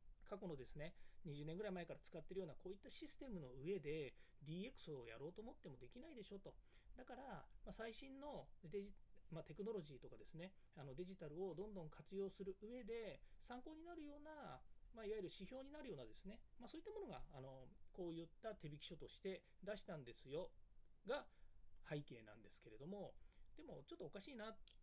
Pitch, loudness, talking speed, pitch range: 195 Hz, -55 LUFS, 415 characters per minute, 160-225 Hz